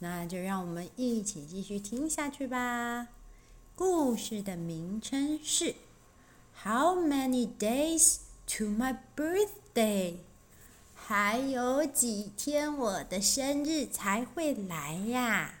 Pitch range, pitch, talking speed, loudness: 200-285 Hz, 240 Hz, 210 characters per minute, -31 LUFS